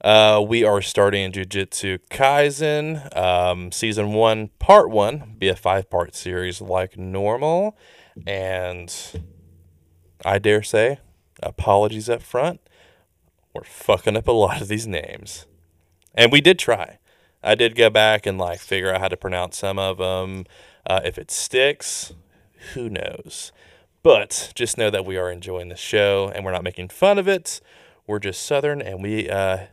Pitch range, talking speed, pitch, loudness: 90-110 Hz, 160 wpm, 95 Hz, -20 LUFS